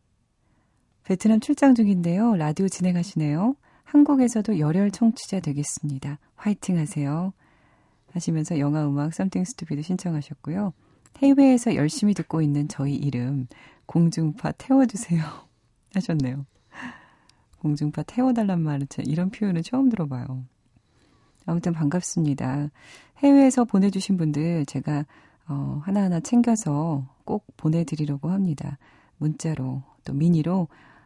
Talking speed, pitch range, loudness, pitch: 315 characters per minute, 145-195 Hz, -24 LUFS, 160 Hz